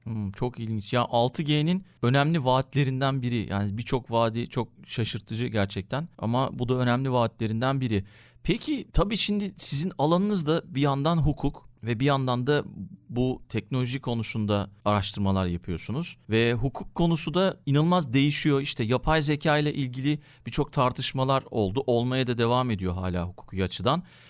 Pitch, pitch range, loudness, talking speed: 130 Hz, 115-150 Hz, -25 LUFS, 145 wpm